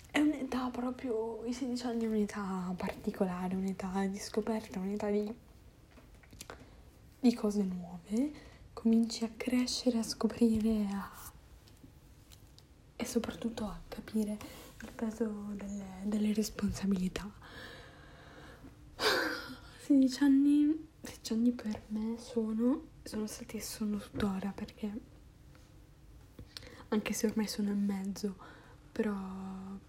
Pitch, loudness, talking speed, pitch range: 220 Hz, -34 LUFS, 100 wpm, 200-235 Hz